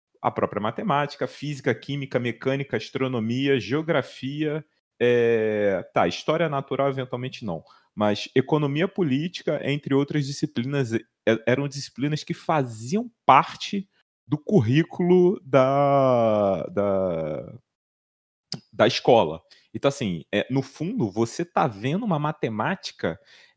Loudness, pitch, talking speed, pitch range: -24 LUFS, 140 Hz, 105 wpm, 120-155 Hz